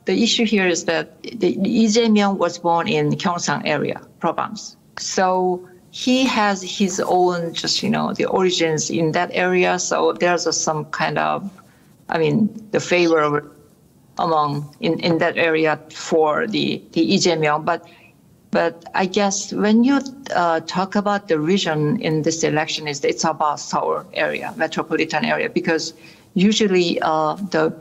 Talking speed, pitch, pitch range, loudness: 155 wpm, 170 Hz, 155-190 Hz, -19 LUFS